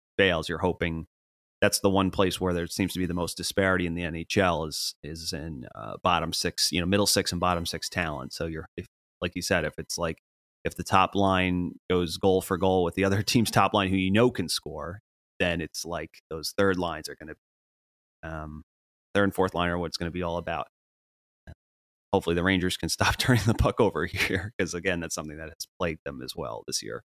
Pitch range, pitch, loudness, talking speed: 80-95 Hz, 90 Hz, -27 LUFS, 235 wpm